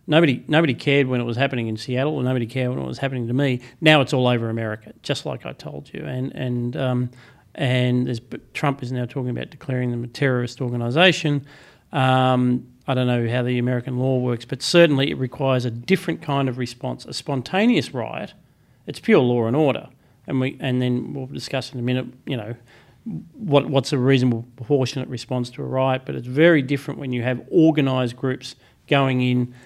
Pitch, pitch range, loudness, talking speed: 130 Hz, 125-140 Hz, -21 LUFS, 205 wpm